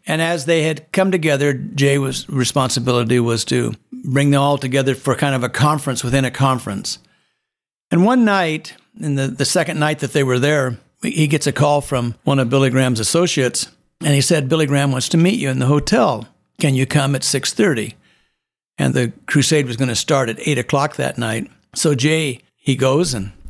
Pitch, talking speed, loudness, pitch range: 140 Hz, 205 wpm, -17 LUFS, 130-155 Hz